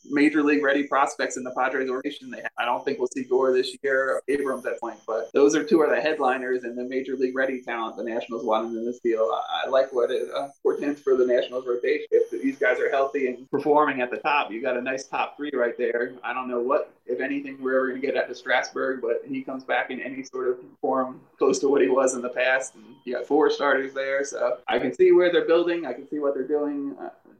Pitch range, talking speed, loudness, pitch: 125-195 Hz, 255 wpm, -25 LUFS, 135 Hz